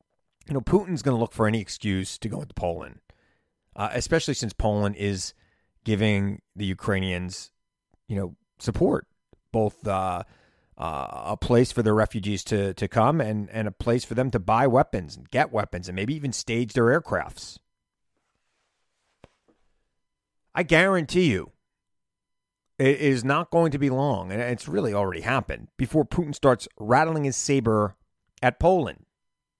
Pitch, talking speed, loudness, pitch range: 110 Hz, 155 wpm, -25 LUFS, 100-135 Hz